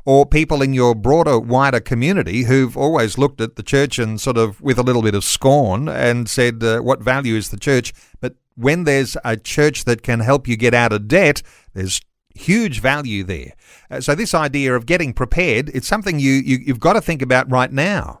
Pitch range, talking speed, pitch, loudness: 115-140 Hz, 215 wpm, 130 Hz, -17 LUFS